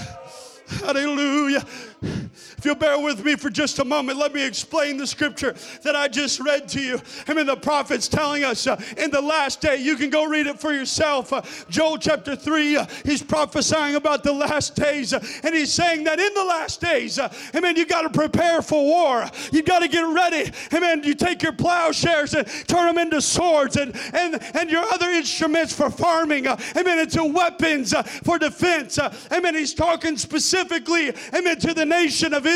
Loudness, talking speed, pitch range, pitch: -21 LUFS, 210 wpm, 285-330 Hz, 305 Hz